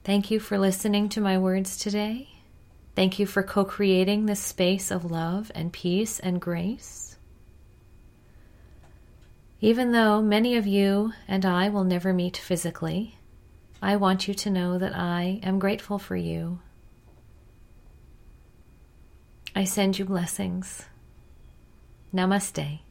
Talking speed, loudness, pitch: 125 wpm, -26 LUFS, 185 Hz